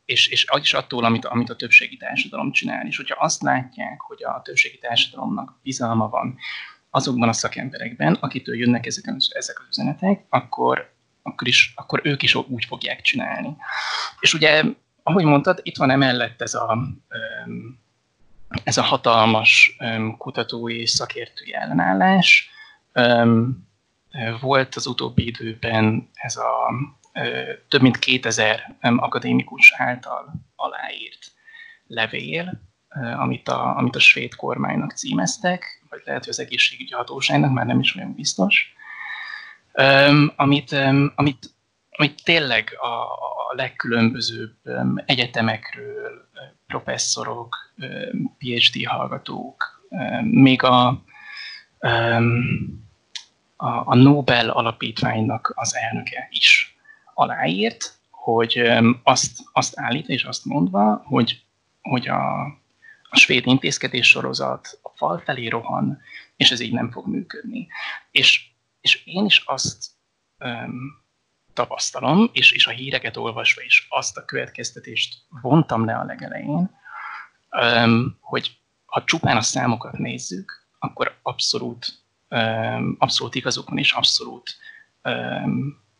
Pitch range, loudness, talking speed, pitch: 115-150 Hz, -19 LUFS, 120 wpm, 130 Hz